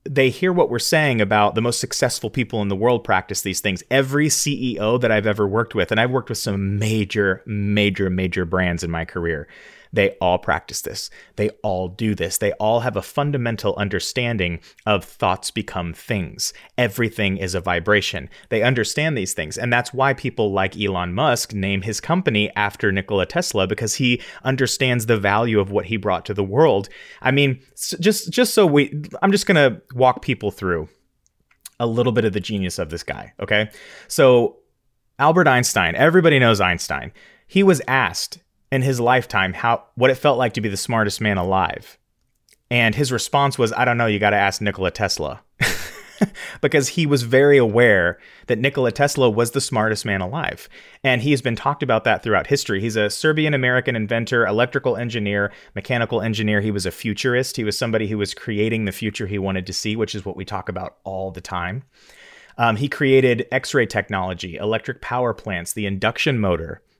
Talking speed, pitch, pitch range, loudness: 190 wpm, 110 Hz, 100-130 Hz, -20 LUFS